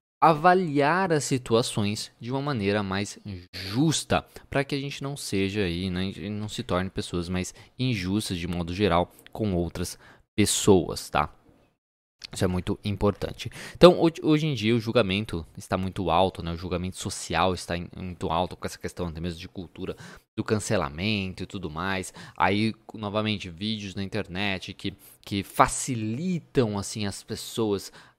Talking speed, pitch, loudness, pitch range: 155 wpm, 100 Hz, -27 LUFS, 95-115 Hz